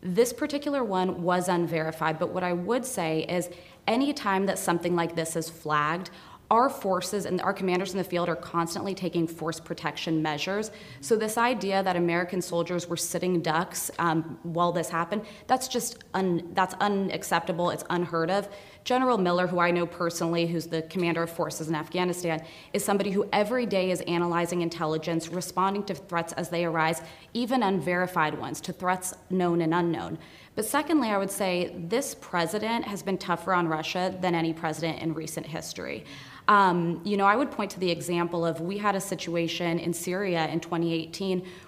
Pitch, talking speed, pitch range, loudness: 175 Hz, 180 wpm, 170-195 Hz, -28 LUFS